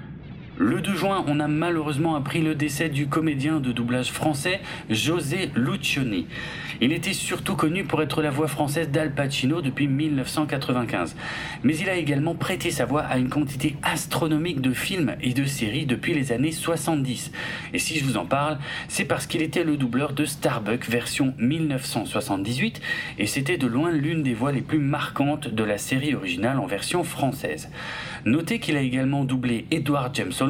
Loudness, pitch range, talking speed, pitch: -25 LUFS, 130-160 Hz, 175 wpm, 150 Hz